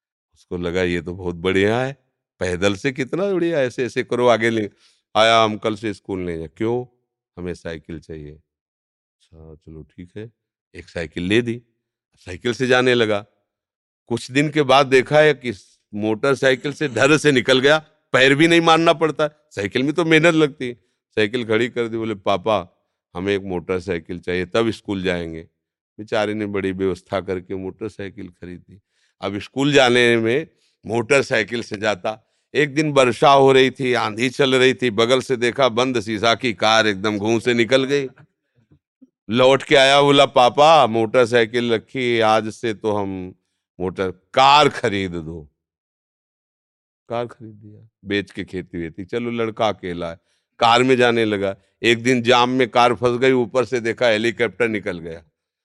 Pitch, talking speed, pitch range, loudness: 115 Hz, 170 wpm, 95-130 Hz, -18 LUFS